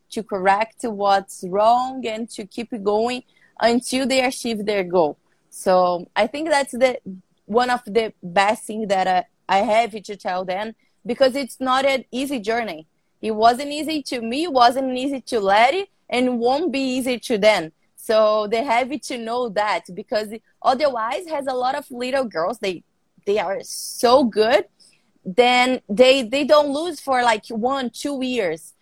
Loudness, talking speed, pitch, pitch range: -20 LUFS, 170 wpm, 235 Hz, 210-260 Hz